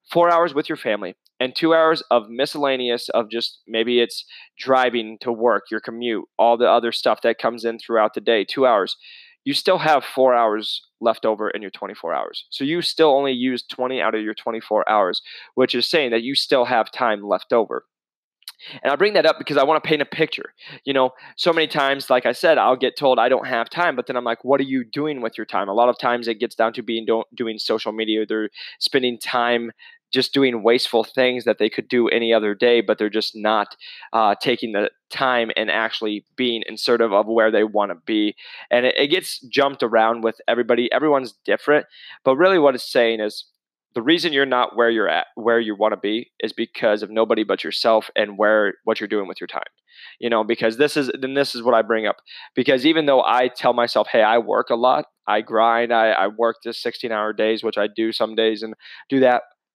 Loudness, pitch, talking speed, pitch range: -20 LUFS, 120 Hz, 230 wpm, 110-135 Hz